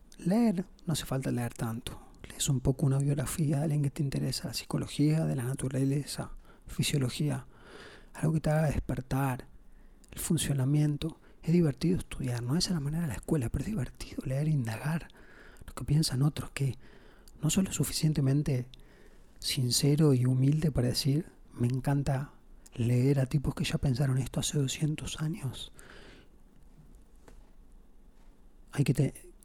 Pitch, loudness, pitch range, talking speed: 145 Hz, -31 LUFS, 130-155 Hz, 155 wpm